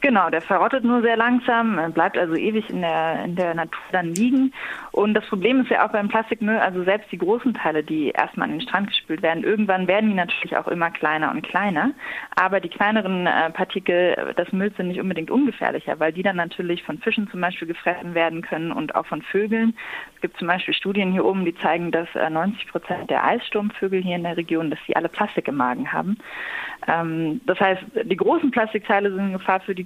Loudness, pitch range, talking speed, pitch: -22 LUFS, 170-215 Hz, 210 wpm, 190 Hz